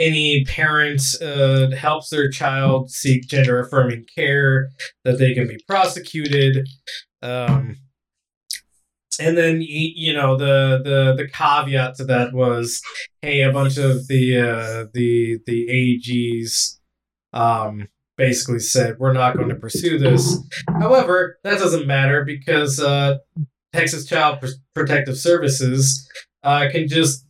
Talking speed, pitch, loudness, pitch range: 130 wpm, 135 Hz, -18 LUFS, 125-150 Hz